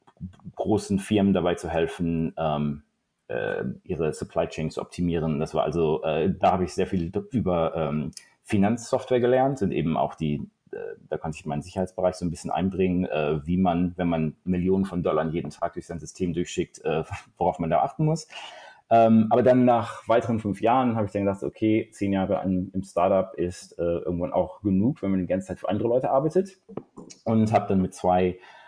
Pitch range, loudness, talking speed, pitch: 85-110 Hz, -25 LUFS, 200 wpm, 95 Hz